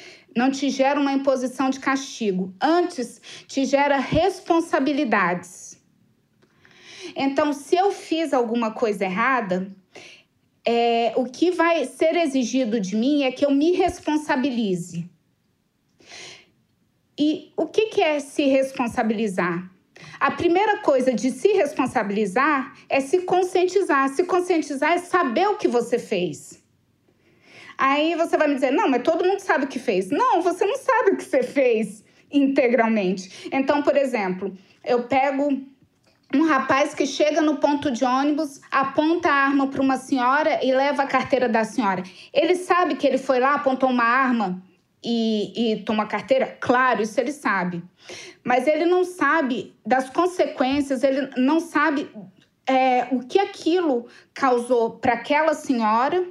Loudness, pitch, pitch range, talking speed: -22 LUFS, 270 Hz, 240-315 Hz, 145 wpm